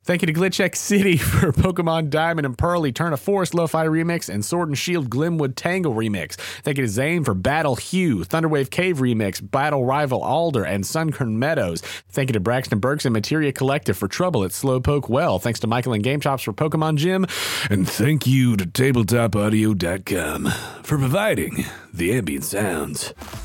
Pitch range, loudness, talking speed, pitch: 115-160 Hz, -21 LUFS, 180 wpm, 135 Hz